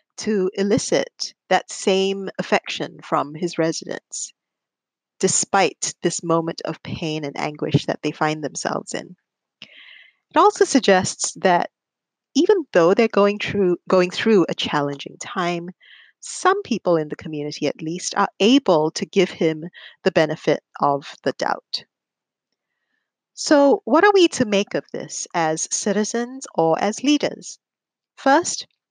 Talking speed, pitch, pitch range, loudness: 135 wpm, 190 Hz, 160-230 Hz, -20 LUFS